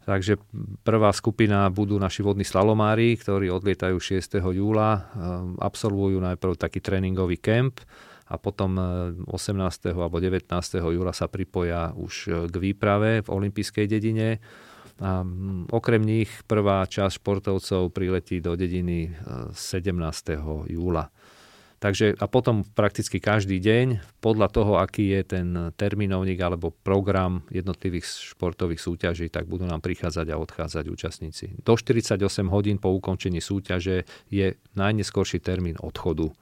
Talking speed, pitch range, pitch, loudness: 125 wpm, 90-105 Hz, 95 Hz, -25 LUFS